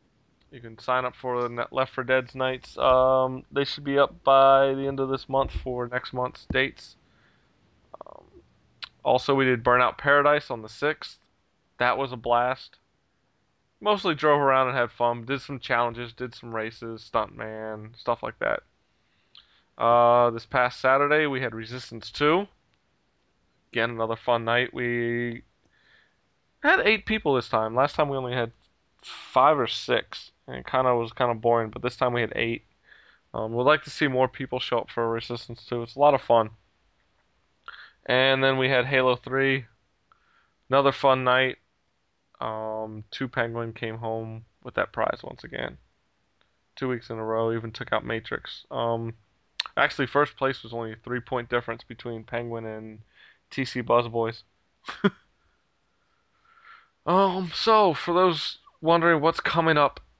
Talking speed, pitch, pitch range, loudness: 160 wpm, 125 Hz, 115-135 Hz, -25 LUFS